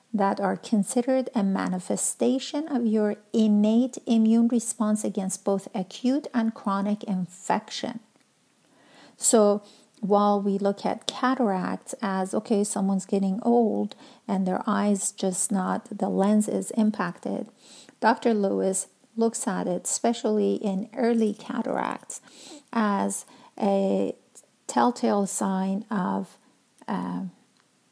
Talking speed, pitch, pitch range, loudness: 110 wpm, 215 Hz, 195-240 Hz, -26 LUFS